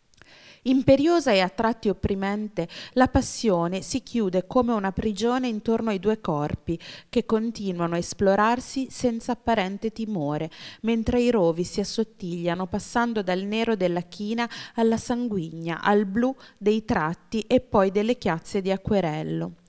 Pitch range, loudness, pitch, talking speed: 180-235 Hz, -25 LUFS, 210 Hz, 135 wpm